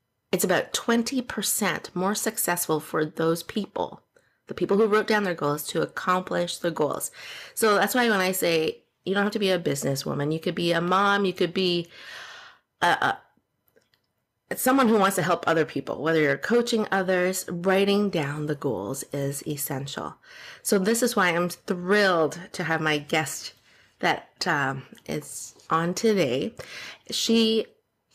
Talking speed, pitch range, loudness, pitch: 160 wpm, 160-210 Hz, -25 LUFS, 180 Hz